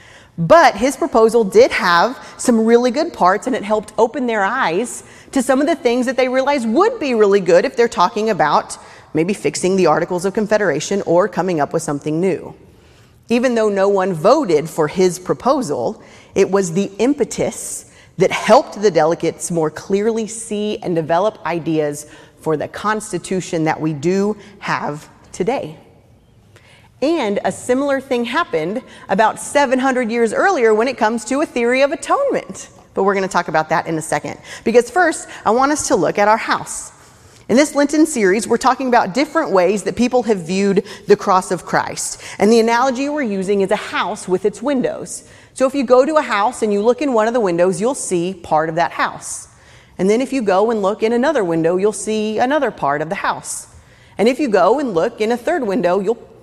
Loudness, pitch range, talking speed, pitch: -16 LUFS, 180-250 Hz, 200 wpm, 215 Hz